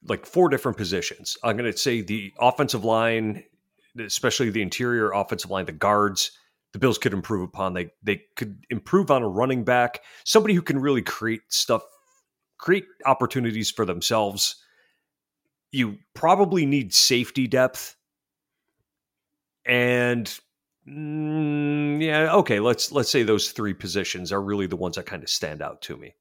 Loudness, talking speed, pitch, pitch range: -23 LUFS, 150 wpm, 125 Hz, 105-145 Hz